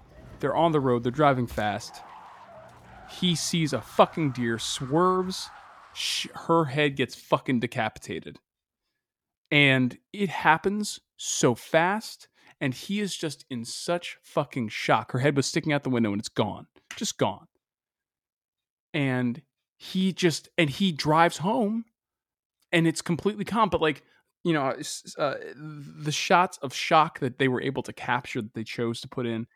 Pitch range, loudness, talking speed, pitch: 125-175 Hz, -26 LUFS, 155 wpm, 150 Hz